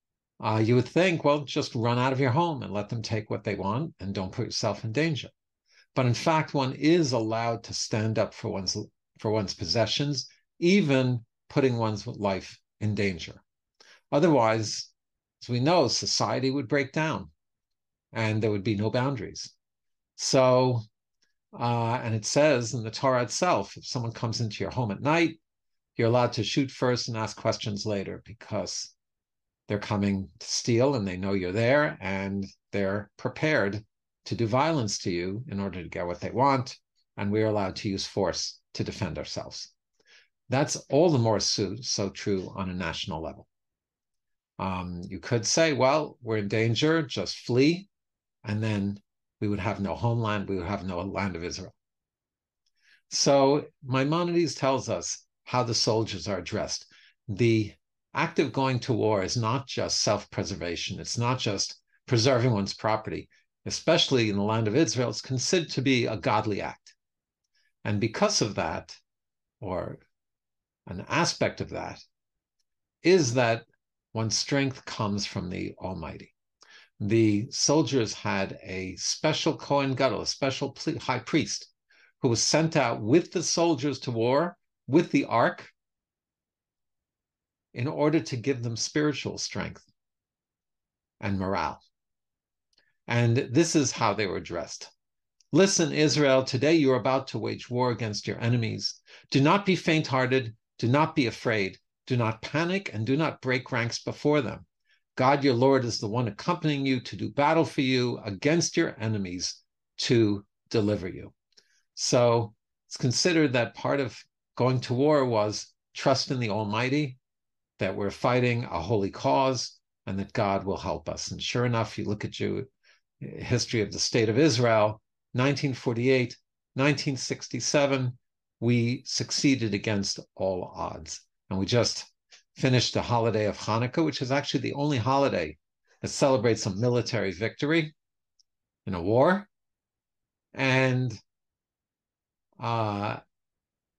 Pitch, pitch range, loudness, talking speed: 120 Hz, 105-135 Hz, -27 LUFS, 155 wpm